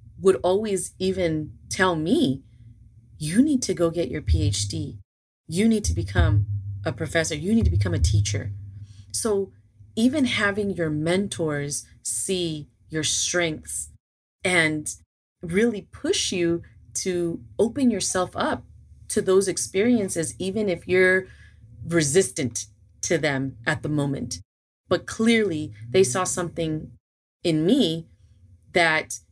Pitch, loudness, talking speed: 160 Hz, -24 LUFS, 125 wpm